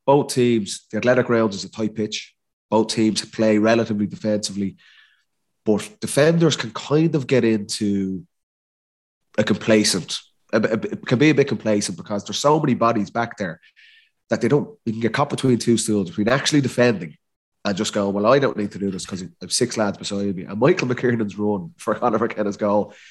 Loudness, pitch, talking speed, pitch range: -21 LUFS, 110 Hz, 195 wpm, 105-130 Hz